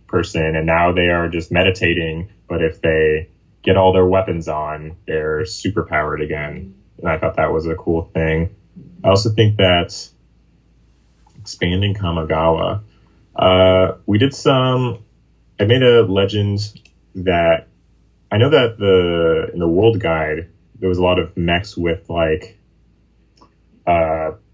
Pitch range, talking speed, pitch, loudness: 80-100 Hz, 140 wpm, 90 Hz, -17 LUFS